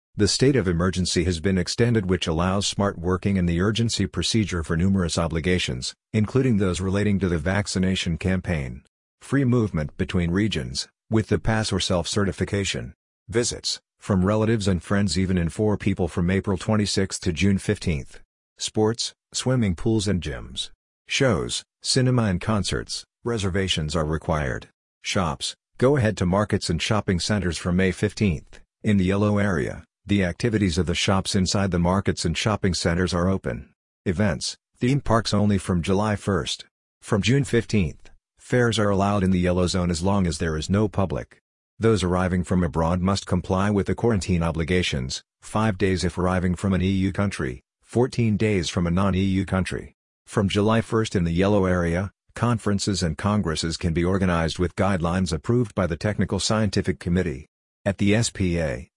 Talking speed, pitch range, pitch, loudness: 165 wpm, 90-105 Hz, 95 Hz, -23 LUFS